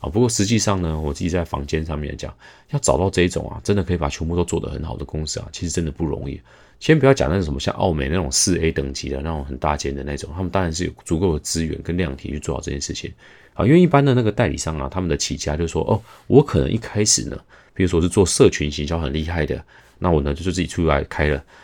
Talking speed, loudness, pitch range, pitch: 395 characters per minute, -20 LUFS, 75-95 Hz, 85 Hz